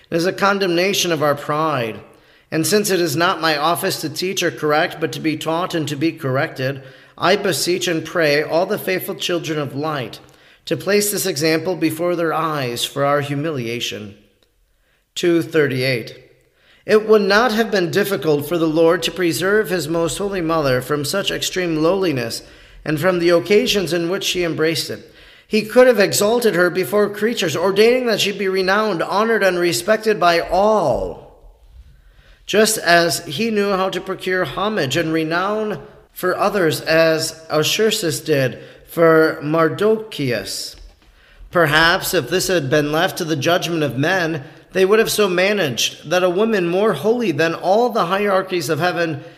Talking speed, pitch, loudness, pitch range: 165 wpm, 170 Hz, -18 LUFS, 155-195 Hz